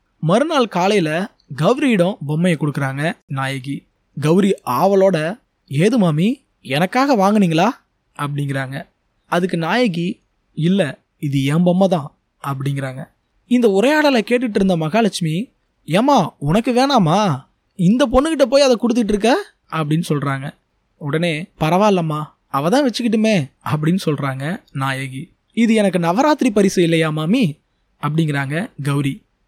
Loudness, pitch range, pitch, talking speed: -17 LUFS, 150-220 Hz, 175 Hz, 105 wpm